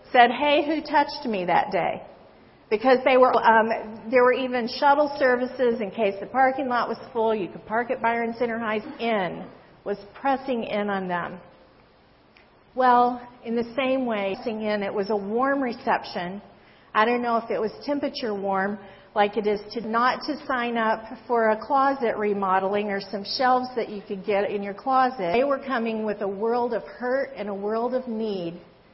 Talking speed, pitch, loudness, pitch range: 190 wpm, 230 Hz, -24 LUFS, 205-255 Hz